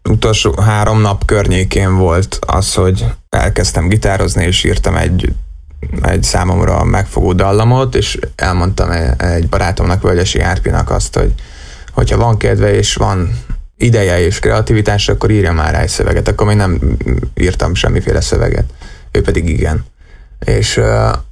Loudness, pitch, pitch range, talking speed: -13 LUFS, 95 Hz, 85-105 Hz, 140 wpm